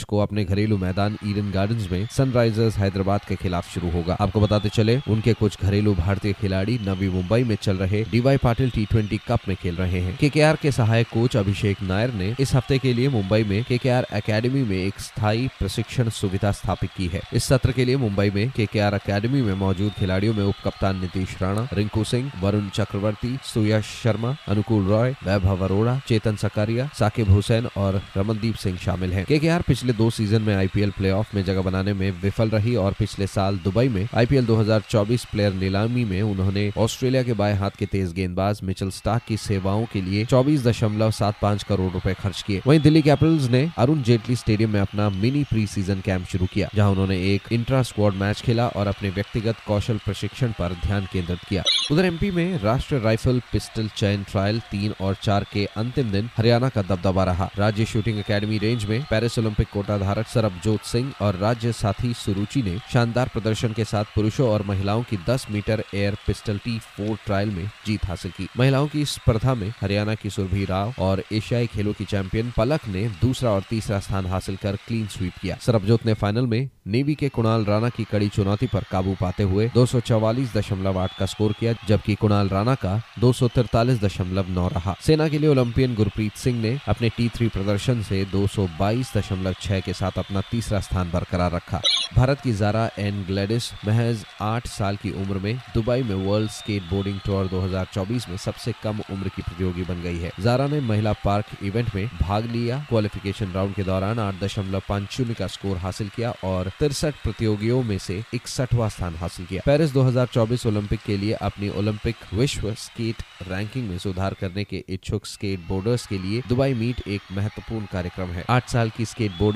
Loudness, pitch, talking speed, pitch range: -23 LUFS, 105 Hz, 185 wpm, 100-115 Hz